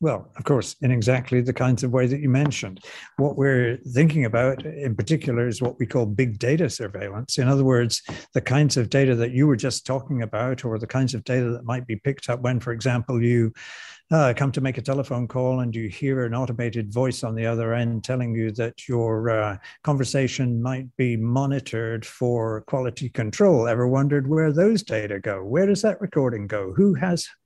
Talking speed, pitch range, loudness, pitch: 205 wpm, 120-135 Hz, -23 LUFS, 125 Hz